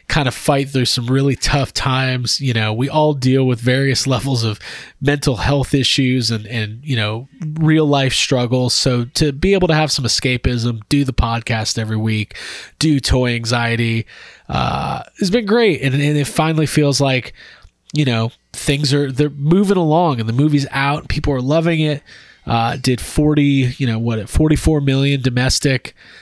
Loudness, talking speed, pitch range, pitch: -16 LUFS, 180 wpm, 120-150 Hz, 135 Hz